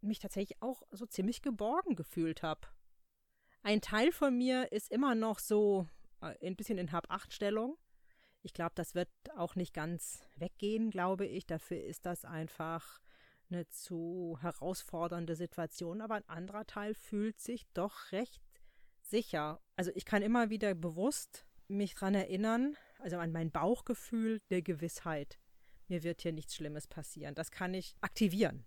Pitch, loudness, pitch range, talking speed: 190 Hz, -38 LUFS, 170-215 Hz, 155 wpm